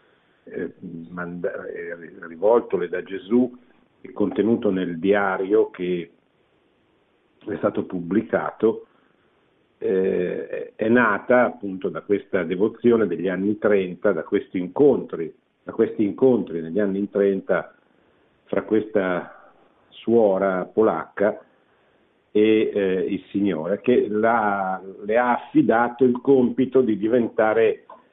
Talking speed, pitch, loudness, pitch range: 100 wpm, 105 Hz, -22 LUFS, 95-125 Hz